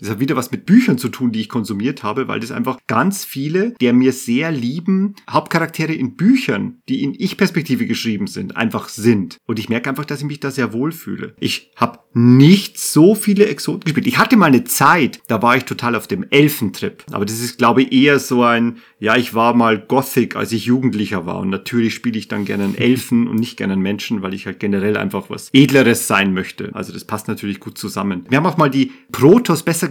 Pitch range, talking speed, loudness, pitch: 115-155 Hz, 225 wpm, -16 LUFS, 125 Hz